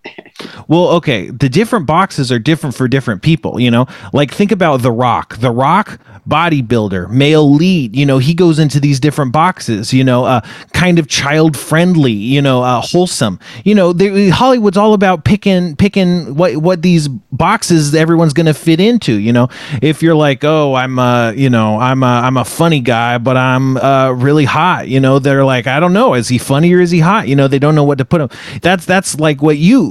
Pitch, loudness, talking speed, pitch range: 150 Hz, -11 LUFS, 220 wpm, 130-175 Hz